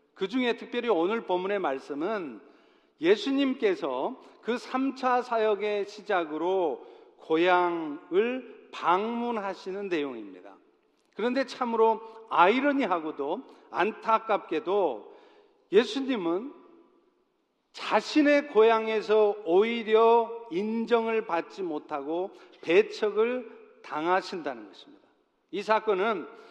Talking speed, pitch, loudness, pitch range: 220 characters per minute, 230 Hz, -27 LUFS, 200-290 Hz